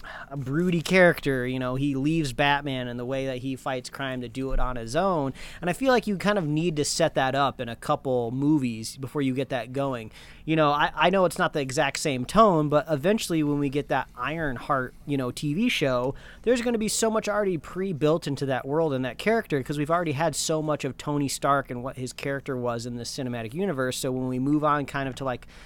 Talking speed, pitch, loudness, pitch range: 250 wpm, 140 Hz, -26 LUFS, 130-160 Hz